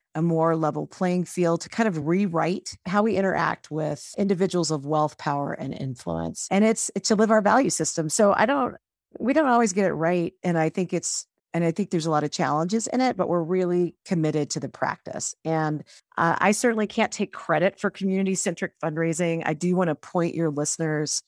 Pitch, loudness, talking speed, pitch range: 175 Hz, -24 LUFS, 210 wpm, 160-195 Hz